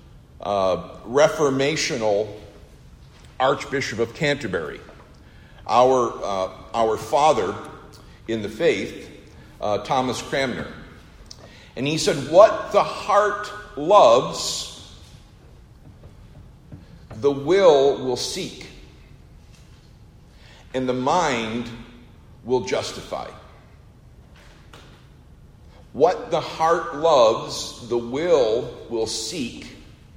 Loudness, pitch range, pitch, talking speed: -21 LUFS, 105-140 Hz, 120 Hz, 75 wpm